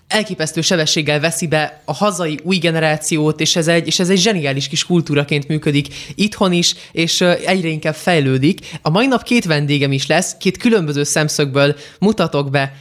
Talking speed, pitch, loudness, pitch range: 170 wpm, 160 Hz, -16 LUFS, 150-180 Hz